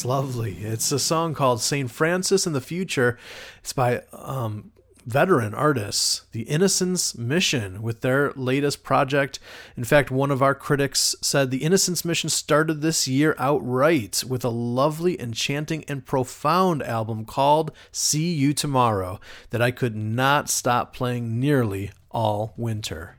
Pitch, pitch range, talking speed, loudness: 135 Hz, 115-150 Hz, 145 wpm, -23 LUFS